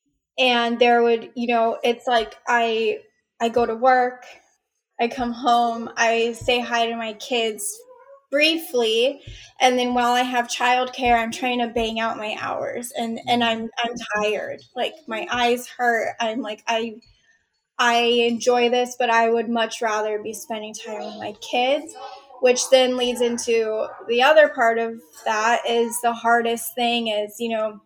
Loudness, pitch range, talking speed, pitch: -21 LUFS, 230-250 Hz, 165 wpm, 235 Hz